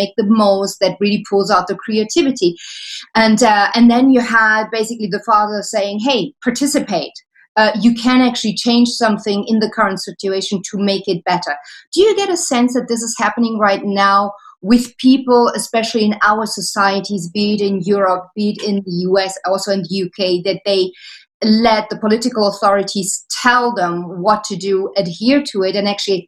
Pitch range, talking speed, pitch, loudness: 195-230 Hz, 185 wpm, 210 Hz, -15 LUFS